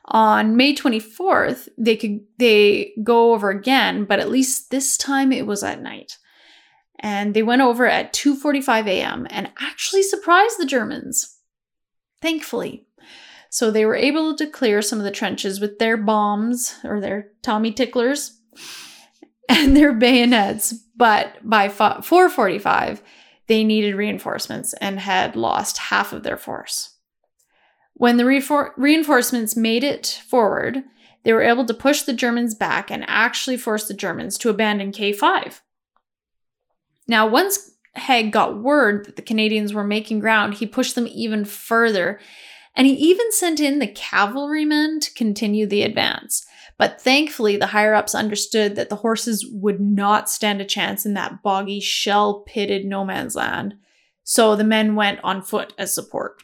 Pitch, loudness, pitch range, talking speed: 230 Hz, -19 LUFS, 210-270 Hz, 150 wpm